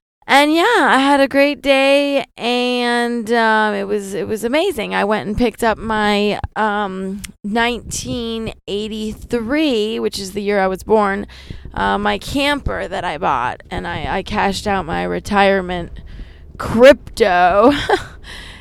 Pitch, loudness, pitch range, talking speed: 215 Hz, -16 LUFS, 195-245 Hz, 140 wpm